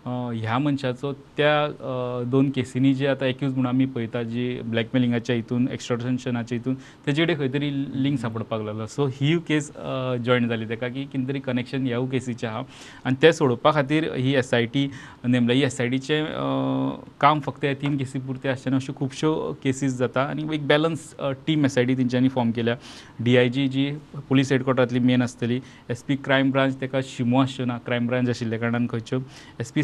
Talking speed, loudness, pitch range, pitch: 180 wpm, -24 LUFS, 120-140 Hz, 130 Hz